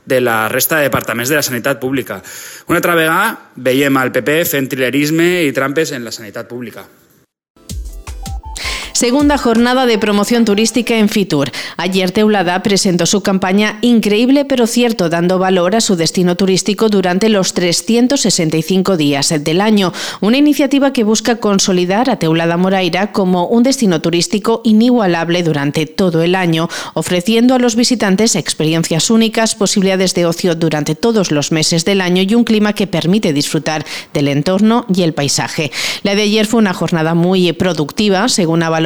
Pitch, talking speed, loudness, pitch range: 185 Hz, 160 wpm, -13 LUFS, 160-220 Hz